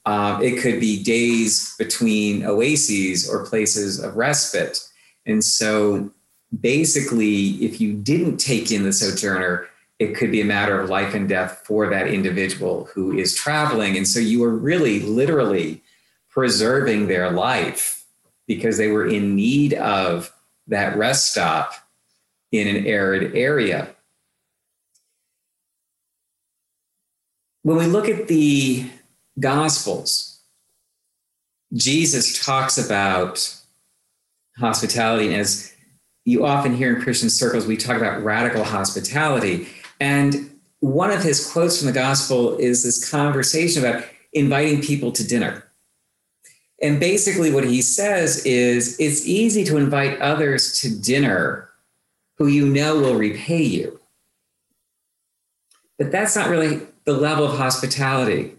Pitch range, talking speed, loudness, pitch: 110-145 Hz, 125 wpm, -19 LUFS, 125 Hz